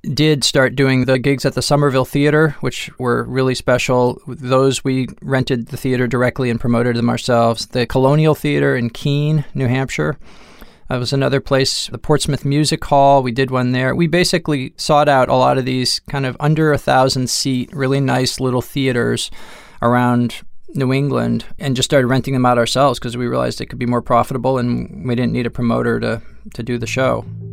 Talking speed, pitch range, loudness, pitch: 195 wpm, 125-140 Hz, -16 LUFS, 130 Hz